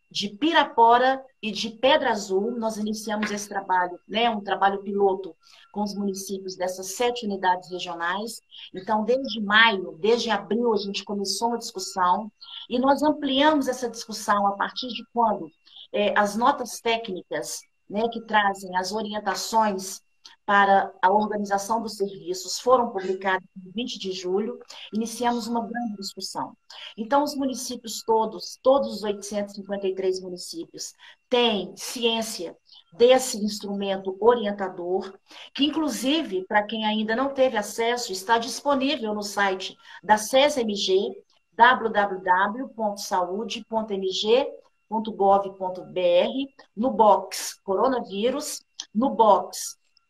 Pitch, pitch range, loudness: 215 Hz, 195-240 Hz, -24 LUFS